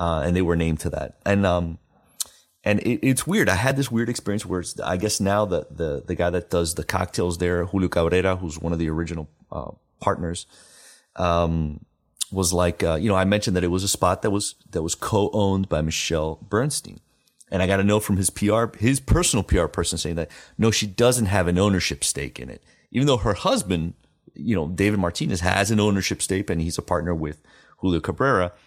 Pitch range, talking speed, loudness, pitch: 85-105 Hz, 220 wpm, -23 LUFS, 95 Hz